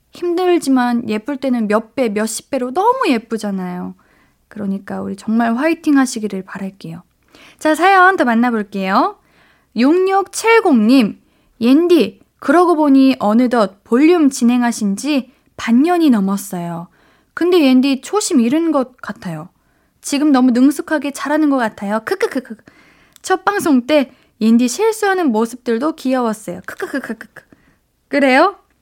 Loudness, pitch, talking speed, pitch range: -15 LUFS, 260 Hz, 275 characters per minute, 220-310 Hz